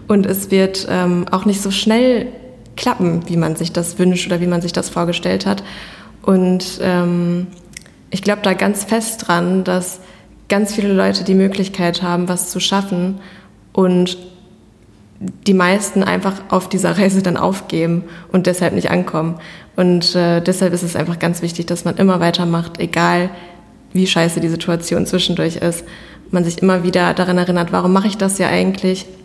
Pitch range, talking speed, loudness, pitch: 175-190 Hz, 170 wpm, -16 LUFS, 180 Hz